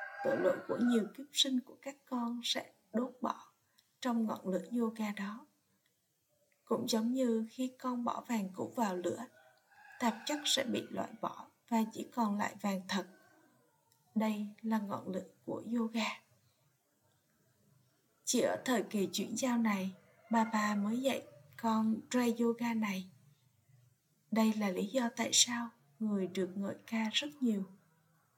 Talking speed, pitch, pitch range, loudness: 150 wpm, 225 Hz, 200-245 Hz, -35 LUFS